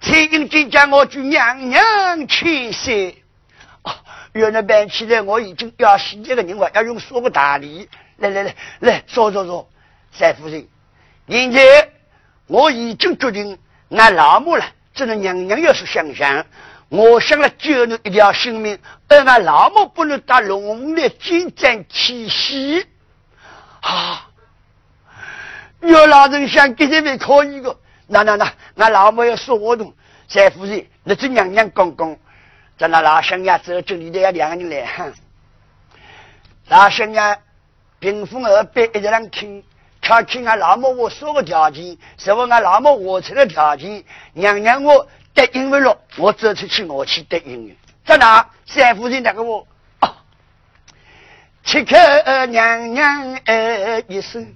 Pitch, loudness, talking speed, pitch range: 225 Hz, -13 LUFS, 185 characters per minute, 195-275 Hz